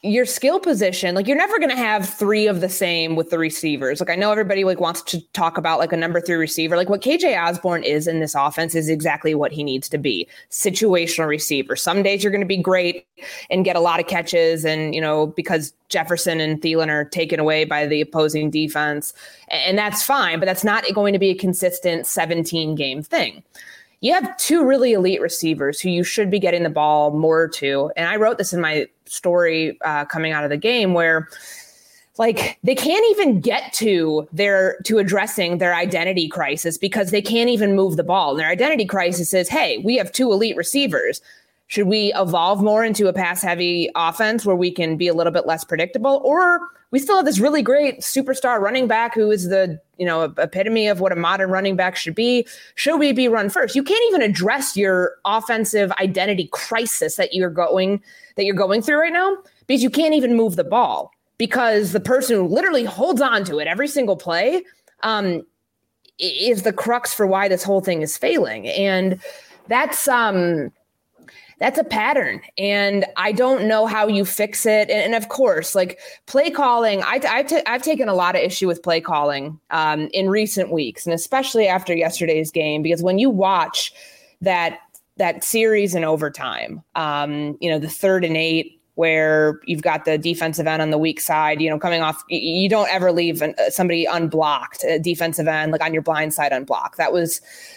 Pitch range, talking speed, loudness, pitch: 165-220 Hz, 200 wpm, -19 LUFS, 185 Hz